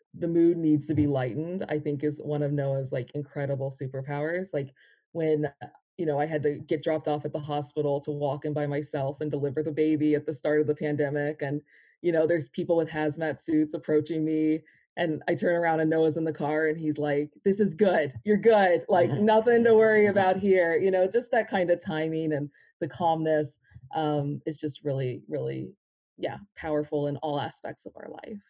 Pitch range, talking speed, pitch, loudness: 145-170 Hz, 210 wpm, 155 Hz, -27 LUFS